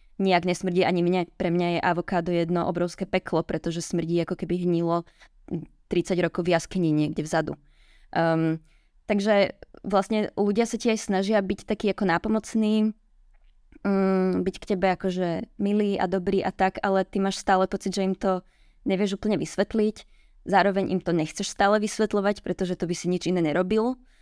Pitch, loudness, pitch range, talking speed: 190 Hz, -25 LUFS, 175-205 Hz, 170 wpm